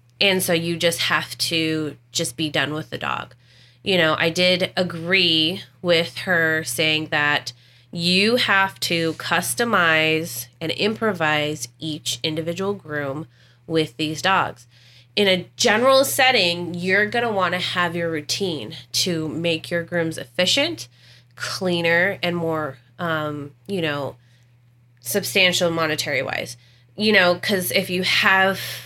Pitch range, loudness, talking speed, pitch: 145-180 Hz, -20 LUFS, 135 wpm, 165 Hz